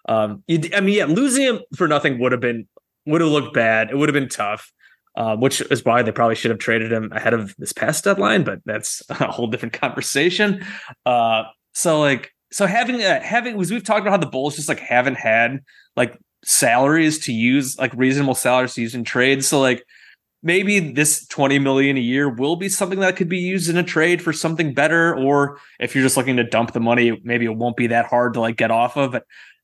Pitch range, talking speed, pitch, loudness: 120-165 Hz, 225 wpm, 135 Hz, -19 LUFS